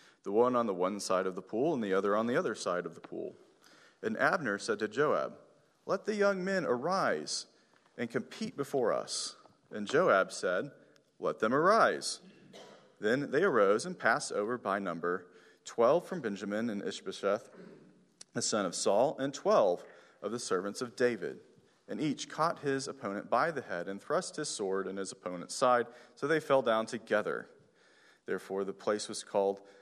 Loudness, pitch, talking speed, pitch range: -32 LUFS, 115 Hz, 180 wpm, 95-135 Hz